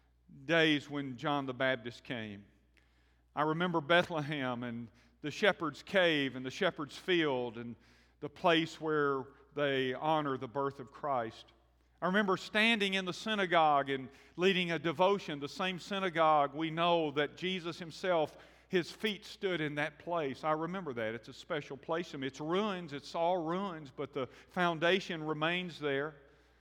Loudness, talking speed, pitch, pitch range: -34 LUFS, 155 wpm, 155 Hz, 135-175 Hz